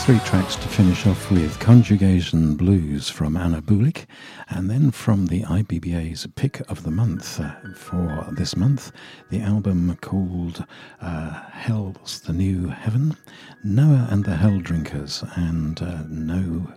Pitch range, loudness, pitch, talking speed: 85-110 Hz, -22 LUFS, 95 Hz, 140 wpm